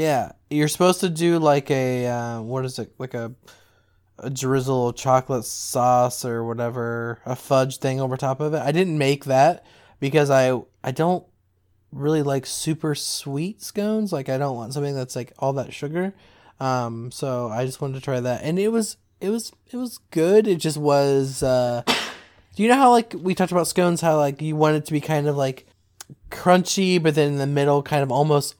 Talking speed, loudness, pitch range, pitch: 205 wpm, -22 LUFS, 125-160 Hz, 140 Hz